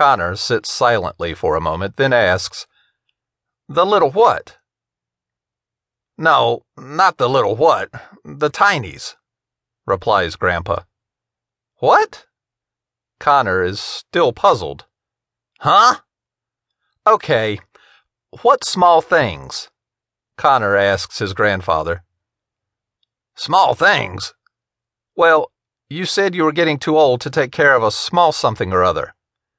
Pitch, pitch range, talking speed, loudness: 125 Hz, 105-160 Hz, 105 wpm, -16 LUFS